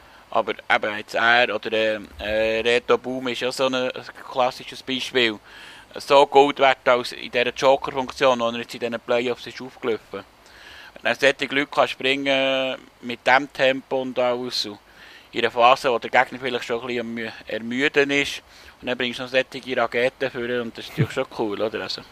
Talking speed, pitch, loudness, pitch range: 175 wpm, 125 Hz, -22 LUFS, 120-130 Hz